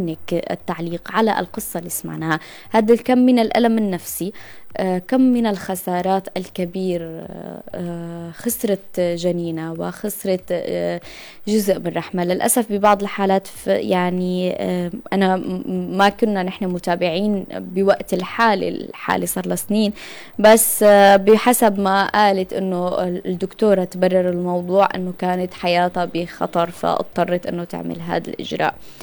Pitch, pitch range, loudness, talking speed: 185 Hz, 175-205 Hz, -19 LUFS, 105 wpm